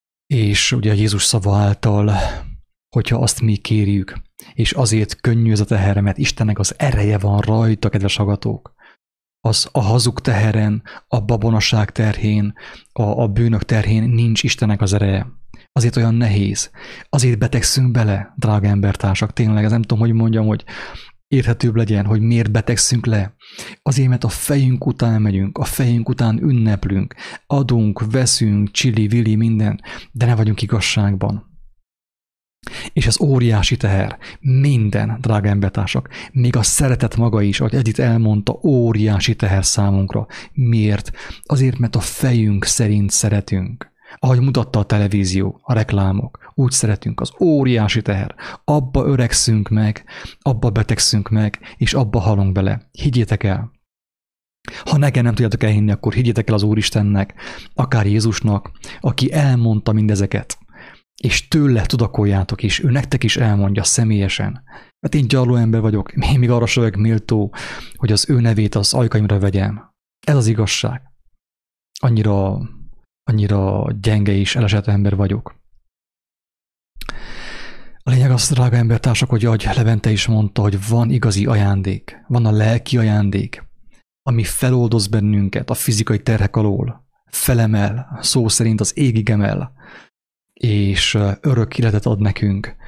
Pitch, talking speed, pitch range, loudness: 110 Hz, 140 wpm, 105-120 Hz, -17 LUFS